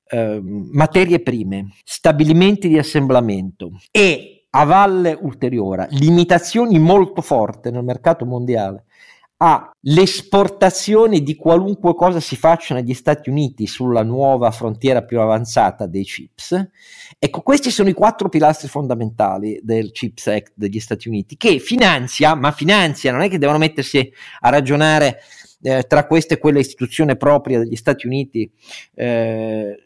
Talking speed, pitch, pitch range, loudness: 130 wpm, 140 Hz, 115-165 Hz, -16 LUFS